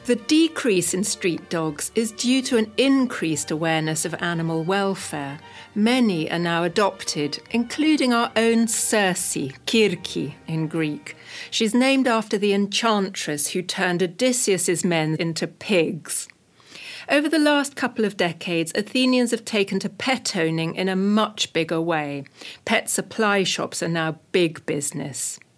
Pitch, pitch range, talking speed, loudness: 190 Hz, 165-230 Hz, 140 wpm, -22 LUFS